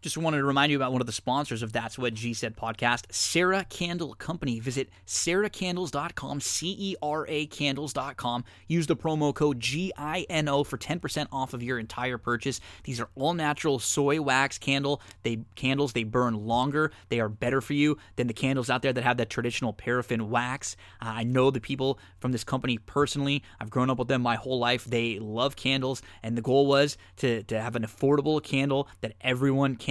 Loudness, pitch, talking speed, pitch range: -28 LUFS, 130 Hz, 190 wpm, 120-145 Hz